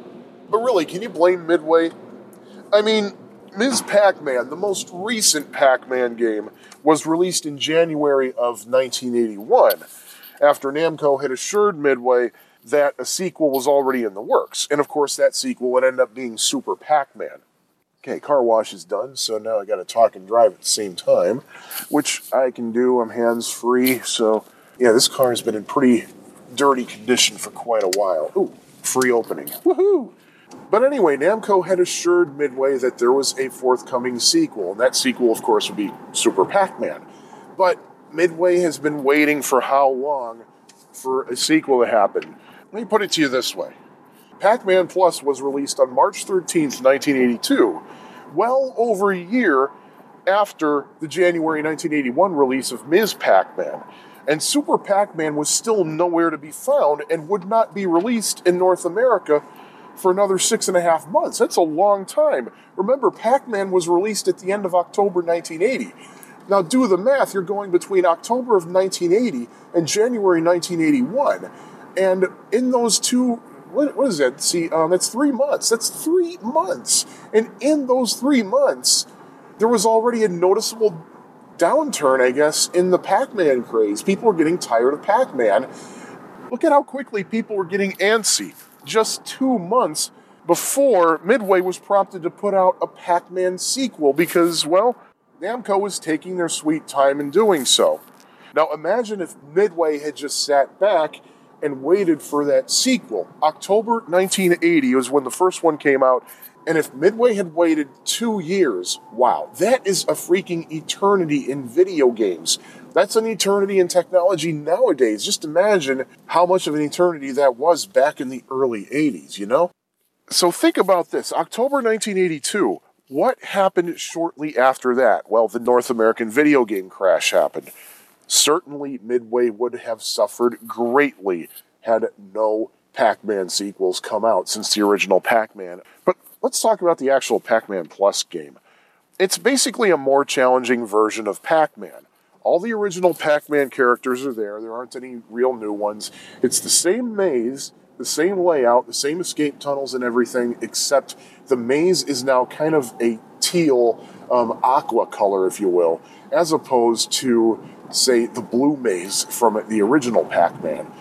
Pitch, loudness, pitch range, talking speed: 175 Hz, -19 LUFS, 140-225 Hz, 165 wpm